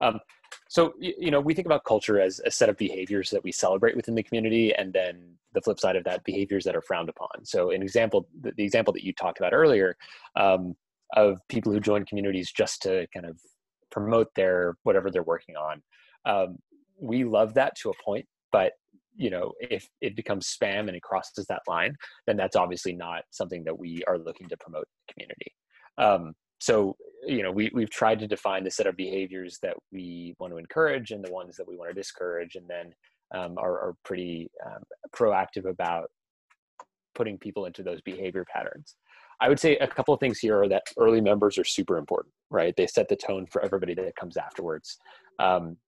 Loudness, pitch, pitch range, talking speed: -27 LUFS, 105 Hz, 90-135 Hz, 205 wpm